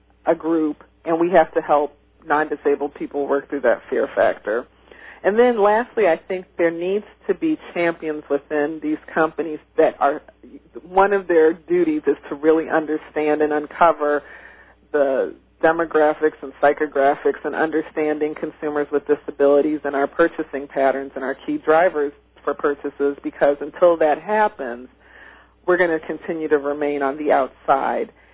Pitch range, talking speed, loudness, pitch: 145-170 Hz, 150 wpm, -20 LUFS, 155 Hz